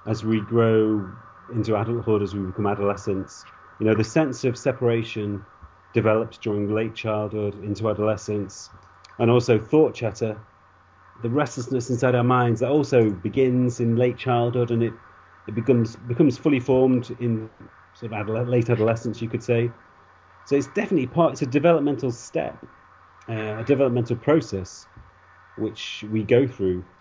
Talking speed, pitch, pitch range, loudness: 150 wpm, 115 Hz, 105-125 Hz, -23 LUFS